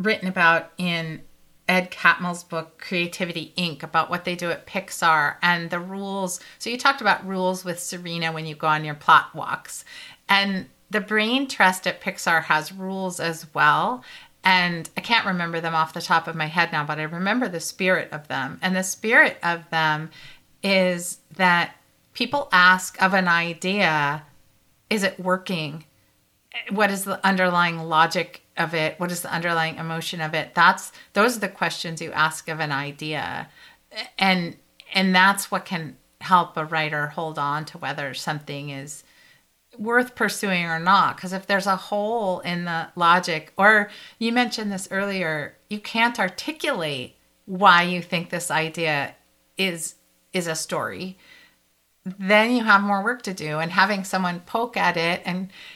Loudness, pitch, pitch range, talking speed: -22 LUFS, 180 Hz, 160-195 Hz, 170 wpm